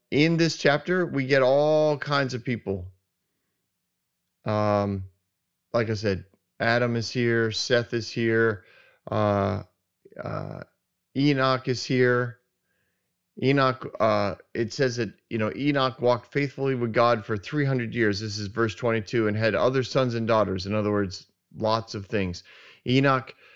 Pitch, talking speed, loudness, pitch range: 115 Hz, 145 wpm, -25 LUFS, 105-130 Hz